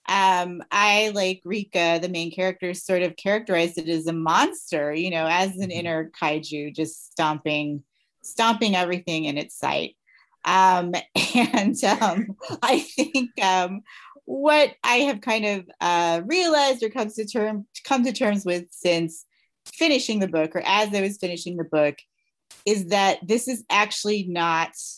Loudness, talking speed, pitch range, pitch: -23 LUFS, 155 wpm, 170-220 Hz, 190 Hz